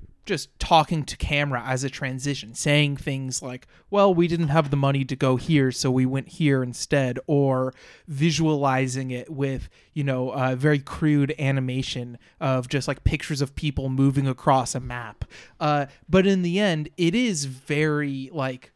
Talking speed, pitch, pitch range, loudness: 170 wpm, 140 Hz, 130-150 Hz, -24 LUFS